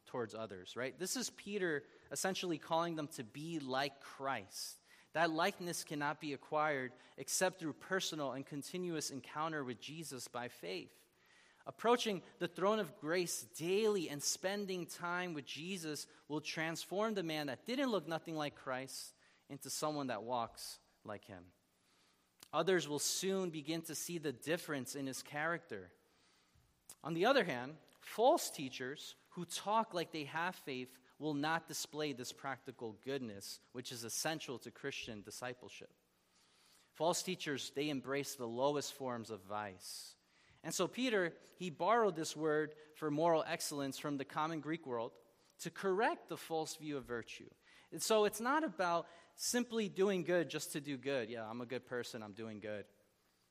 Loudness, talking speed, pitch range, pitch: -40 LUFS, 160 wpm, 130-175 Hz, 150 Hz